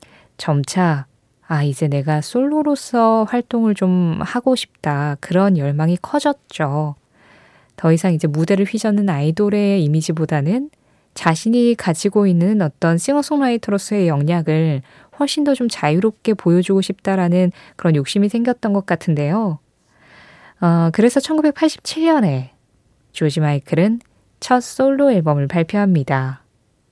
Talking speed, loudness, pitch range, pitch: 270 characters per minute, -17 LUFS, 155-225 Hz, 180 Hz